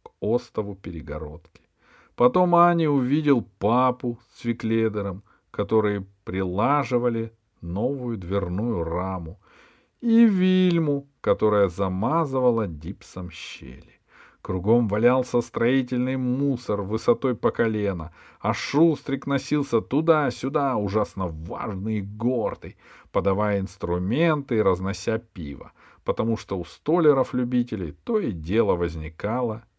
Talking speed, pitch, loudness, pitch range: 95 wpm, 110 Hz, -24 LUFS, 95-130 Hz